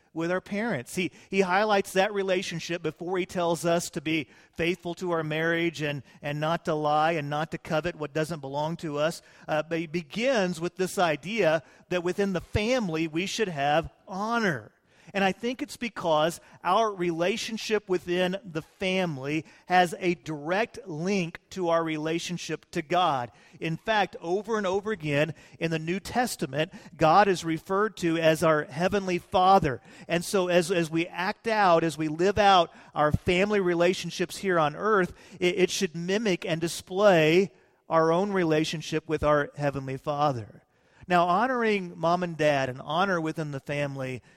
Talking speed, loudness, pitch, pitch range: 170 wpm, -27 LUFS, 175 Hz, 160-190 Hz